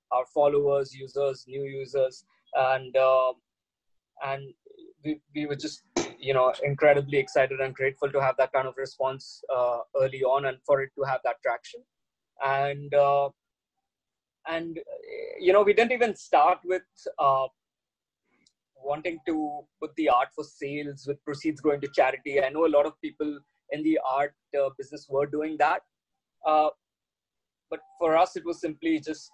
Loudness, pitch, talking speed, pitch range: -27 LUFS, 145 Hz, 160 wpm, 135-155 Hz